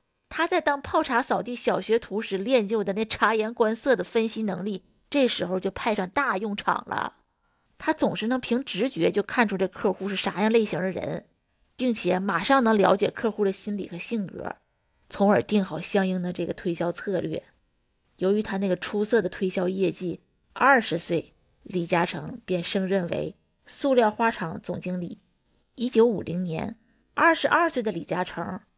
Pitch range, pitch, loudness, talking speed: 185-235 Hz, 205 Hz, -25 LUFS, 260 characters per minute